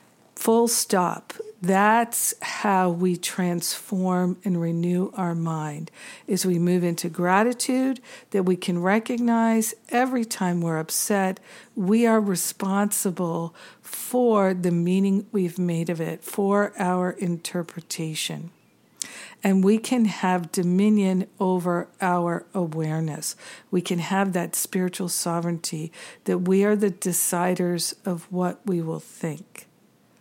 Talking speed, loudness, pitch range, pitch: 120 wpm, -24 LUFS, 175-205 Hz, 185 Hz